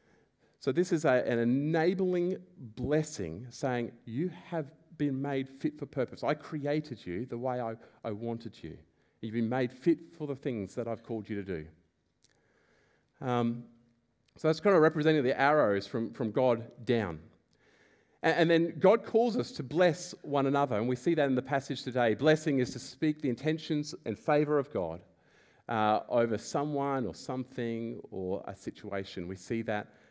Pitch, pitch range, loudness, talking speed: 130 Hz, 115-155 Hz, -31 LUFS, 175 wpm